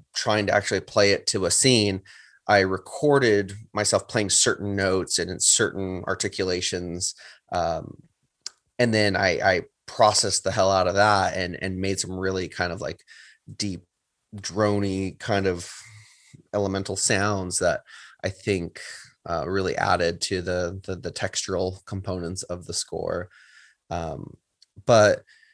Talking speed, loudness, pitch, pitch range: 140 wpm, -24 LUFS, 95 Hz, 90-105 Hz